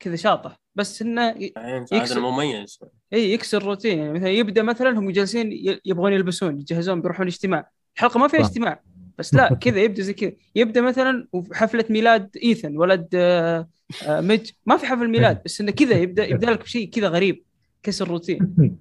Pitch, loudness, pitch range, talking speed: 200 Hz, -21 LUFS, 175-230 Hz, 155 wpm